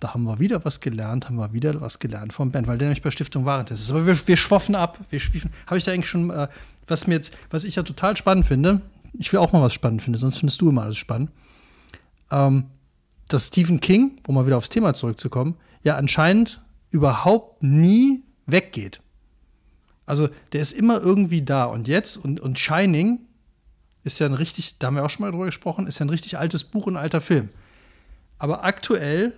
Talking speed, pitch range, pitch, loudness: 215 wpm, 125-180 Hz, 150 Hz, -21 LUFS